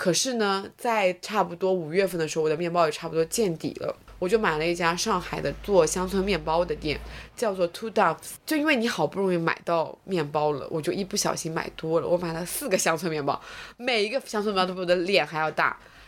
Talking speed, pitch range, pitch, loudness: 355 characters per minute, 160-200 Hz, 175 Hz, -26 LUFS